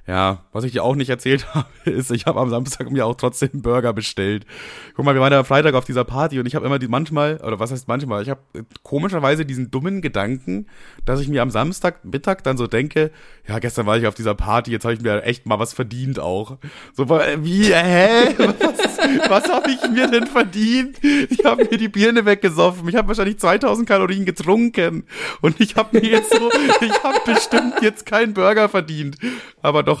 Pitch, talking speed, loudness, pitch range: 140 Hz, 210 wpm, -18 LUFS, 120-200 Hz